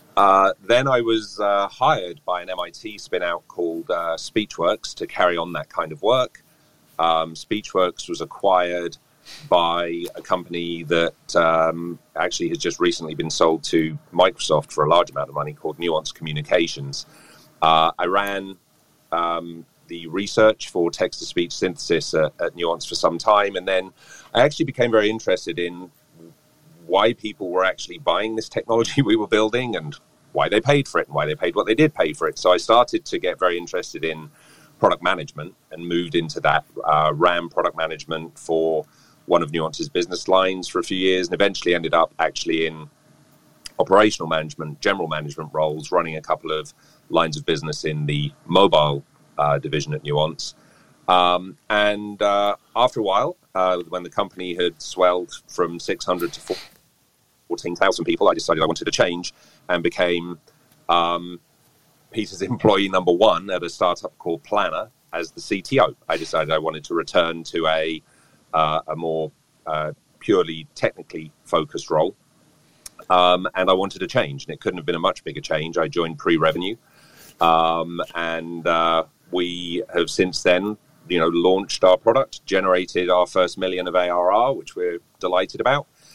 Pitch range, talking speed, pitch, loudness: 80-95 Hz, 170 wpm, 85 Hz, -21 LUFS